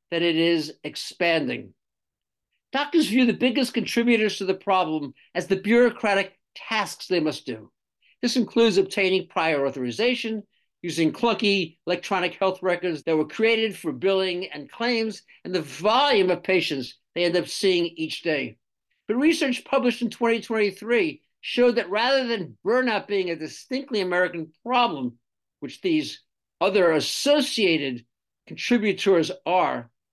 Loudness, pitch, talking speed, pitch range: -23 LUFS, 195 Hz, 135 wpm, 170-235 Hz